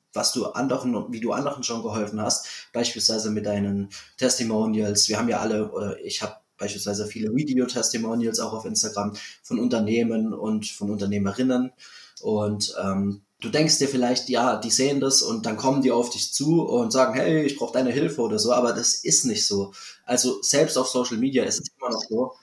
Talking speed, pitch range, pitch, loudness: 190 wpm, 105-130 Hz, 115 Hz, -23 LUFS